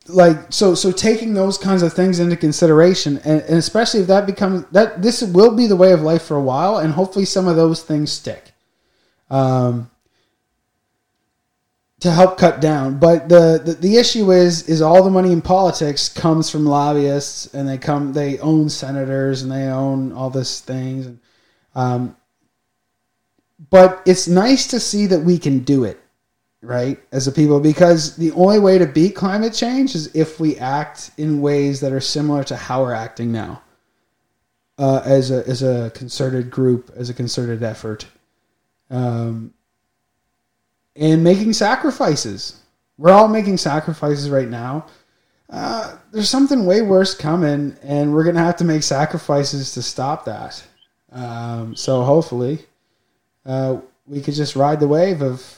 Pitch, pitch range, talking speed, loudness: 150 Hz, 130-180 Hz, 165 wpm, -16 LUFS